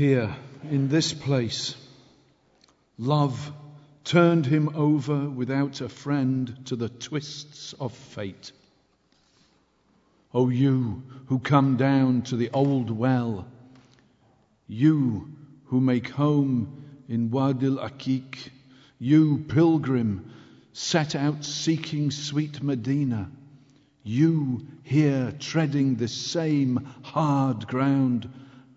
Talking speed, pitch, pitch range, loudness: 100 wpm, 135 Hz, 125-145 Hz, -25 LUFS